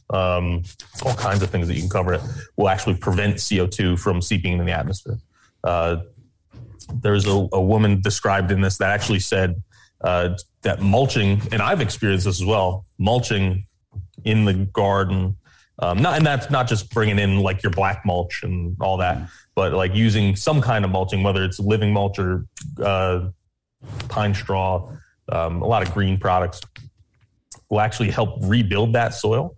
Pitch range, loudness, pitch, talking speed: 95-110 Hz, -21 LUFS, 100 Hz, 175 wpm